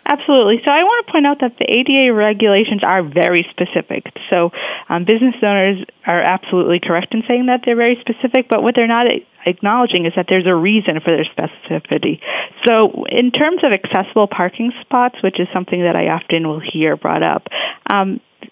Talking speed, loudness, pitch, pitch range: 190 wpm, -15 LUFS, 210 Hz, 180-245 Hz